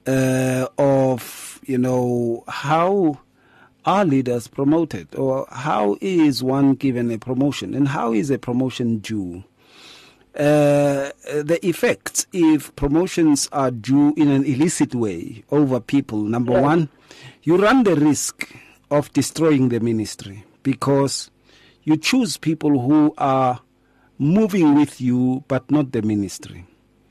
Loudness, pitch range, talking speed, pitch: -19 LUFS, 125-150 Hz, 125 wpm, 135 Hz